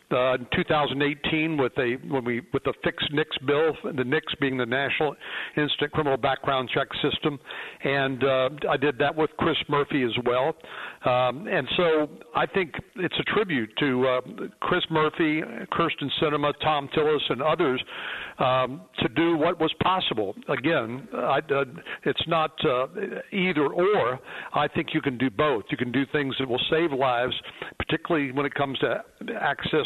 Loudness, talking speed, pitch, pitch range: -25 LUFS, 160 wpm, 145 Hz, 130-160 Hz